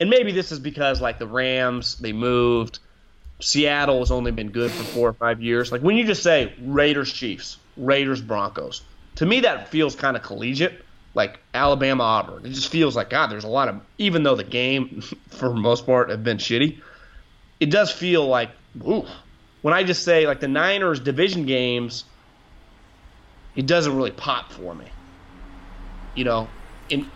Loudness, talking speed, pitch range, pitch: -21 LUFS, 180 wpm, 110-145 Hz, 125 Hz